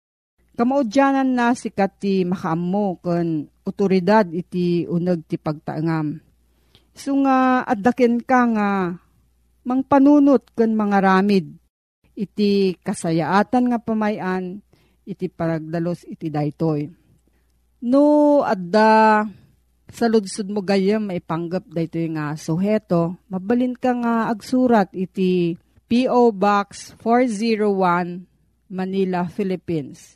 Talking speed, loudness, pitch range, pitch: 100 wpm, -20 LUFS, 170-230 Hz, 195 Hz